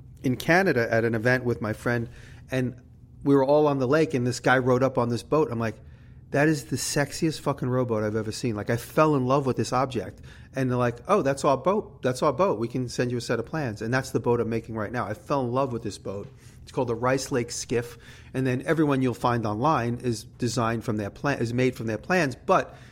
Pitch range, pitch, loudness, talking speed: 115-135 Hz, 125 Hz, -26 LUFS, 255 wpm